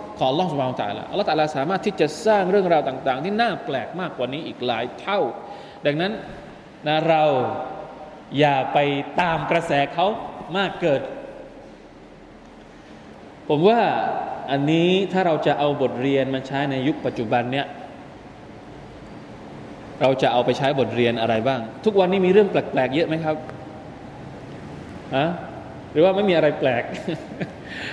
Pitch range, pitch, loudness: 135-185 Hz, 150 Hz, -22 LUFS